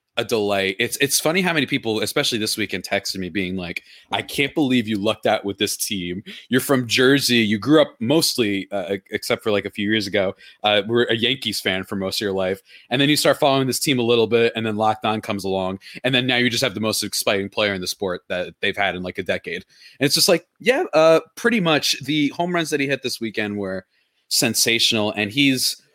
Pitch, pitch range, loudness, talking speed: 115 Hz, 100-140 Hz, -20 LUFS, 240 wpm